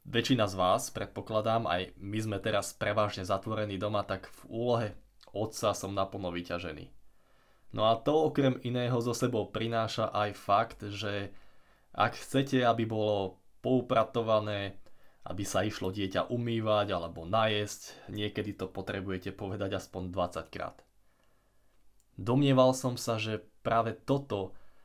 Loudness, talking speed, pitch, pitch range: -32 LUFS, 130 wpm, 105 Hz, 100-115 Hz